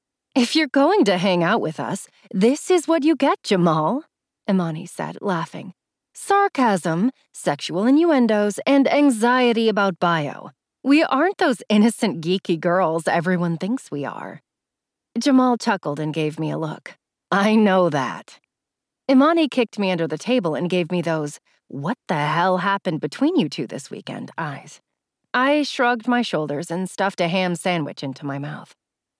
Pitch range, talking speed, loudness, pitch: 170-255 Hz, 155 wpm, -20 LUFS, 200 Hz